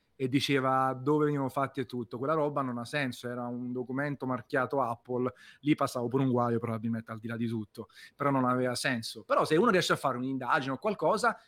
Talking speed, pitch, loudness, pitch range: 215 wpm, 130 Hz, -31 LUFS, 120-140 Hz